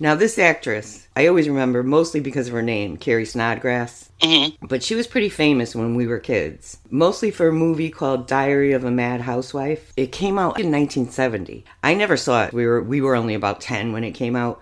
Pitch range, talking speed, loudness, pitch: 115-155 Hz, 220 wpm, -20 LUFS, 130 Hz